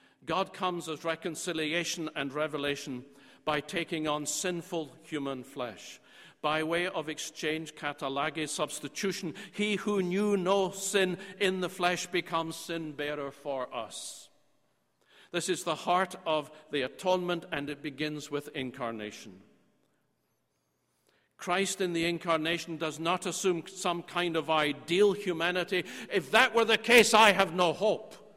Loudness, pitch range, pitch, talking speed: -30 LUFS, 150-185 Hz, 165 Hz, 135 wpm